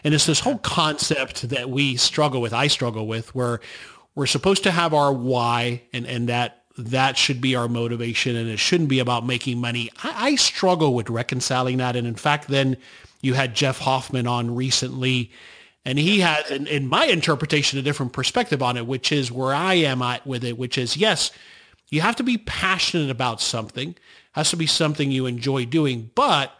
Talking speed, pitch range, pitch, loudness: 200 wpm, 120-150 Hz, 130 Hz, -21 LUFS